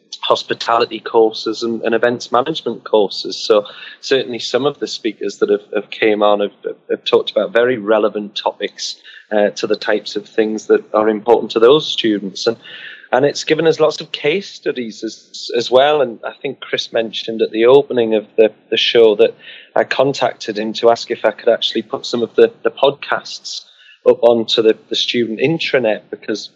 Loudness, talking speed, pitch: -16 LUFS, 190 wpm, 125 Hz